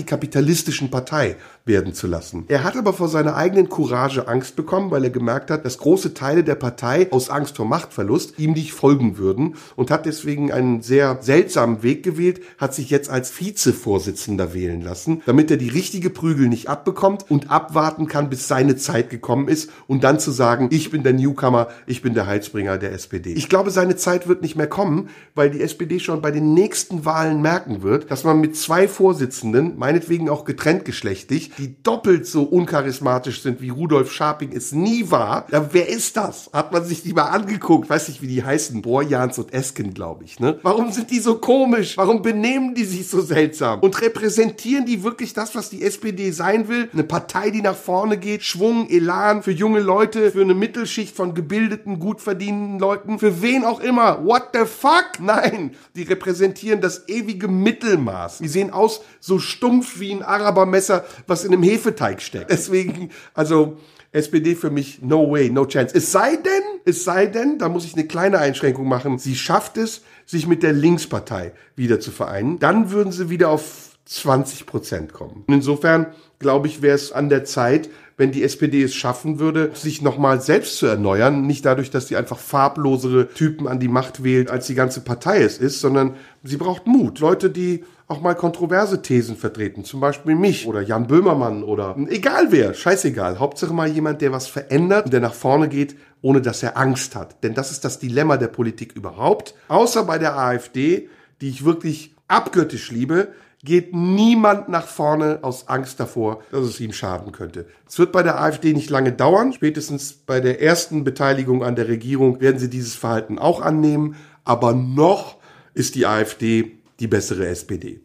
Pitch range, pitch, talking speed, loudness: 130-185 Hz, 155 Hz, 190 wpm, -19 LUFS